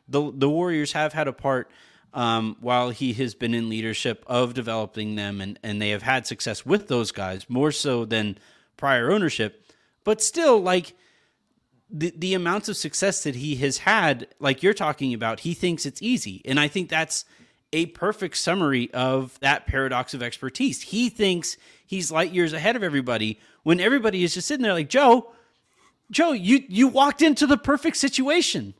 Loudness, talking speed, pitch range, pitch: -23 LUFS, 180 wpm, 125-195 Hz, 150 Hz